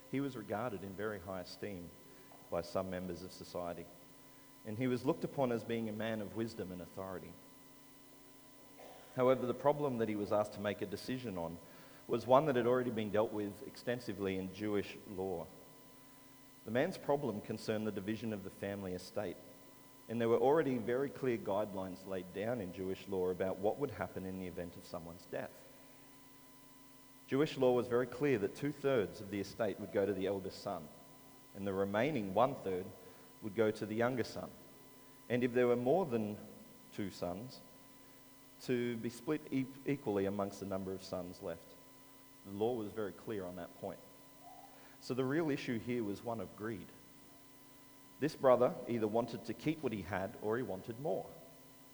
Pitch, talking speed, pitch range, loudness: 110 Hz, 180 wpm, 95-125 Hz, -38 LUFS